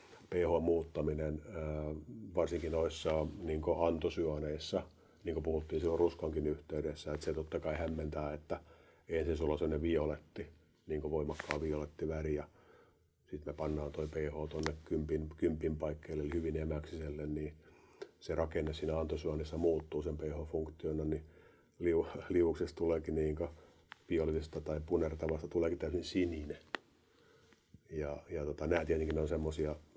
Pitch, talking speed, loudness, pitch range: 80 Hz, 130 wpm, -38 LUFS, 75-80 Hz